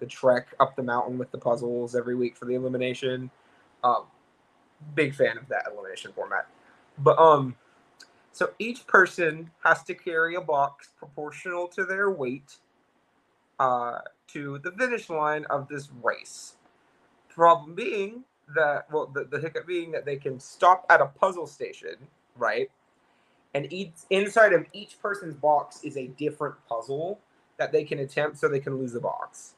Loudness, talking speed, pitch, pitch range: -26 LUFS, 160 wpm, 155 Hz, 135-200 Hz